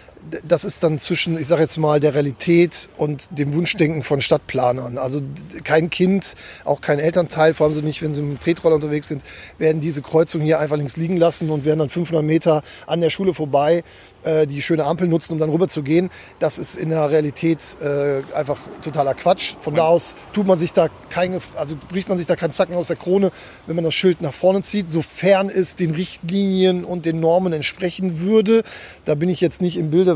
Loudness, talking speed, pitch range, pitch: -19 LUFS, 215 wpm, 155-175 Hz, 165 Hz